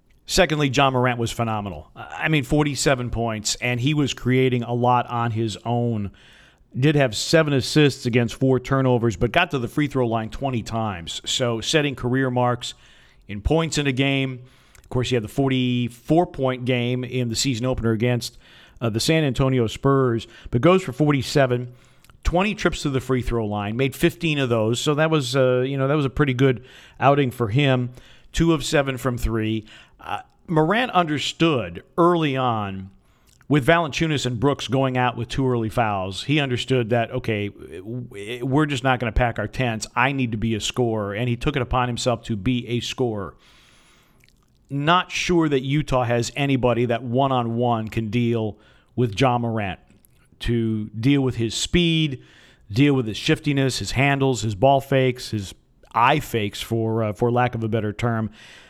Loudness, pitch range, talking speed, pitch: -22 LUFS, 115-140 Hz, 180 wpm, 125 Hz